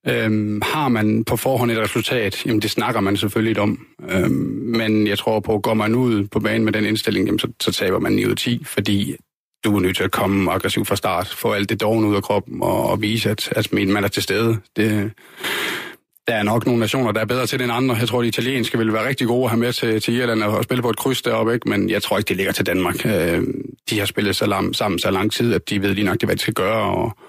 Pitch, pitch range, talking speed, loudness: 110 Hz, 105-120 Hz, 270 wpm, -19 LUFS